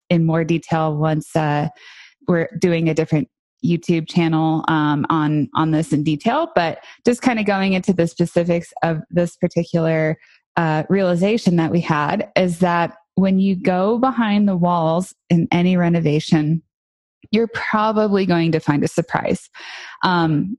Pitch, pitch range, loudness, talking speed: 170 Hz, 160-190 Hz, -19 LUFS, 150 wpm